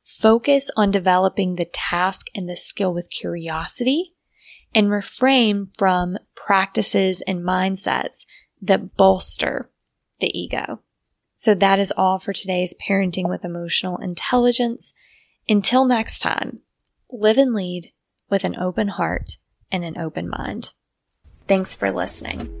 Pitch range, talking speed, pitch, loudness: 180-215 Hz, 125 wpm, 190 Hz, -19 LUFS